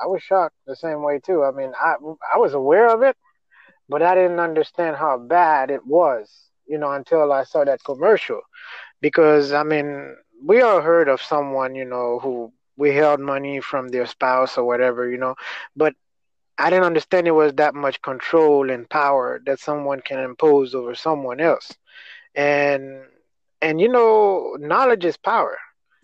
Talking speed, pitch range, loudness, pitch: 175 wpm, 135-165 Hz, -19 LUFS, 145 Hz